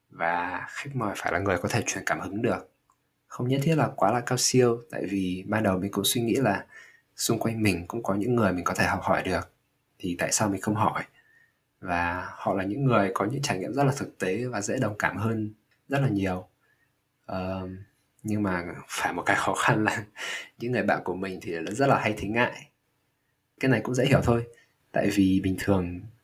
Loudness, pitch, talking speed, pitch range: -27 LUFS, 105 Hz, 225 wpm, 95-120 Hz